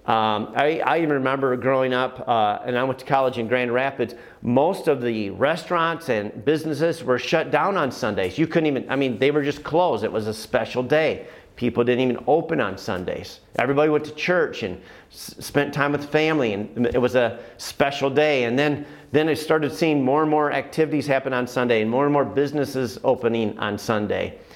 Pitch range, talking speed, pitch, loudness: 125-150 Hz, 205 wpm, 135 Hz, -22 LUFS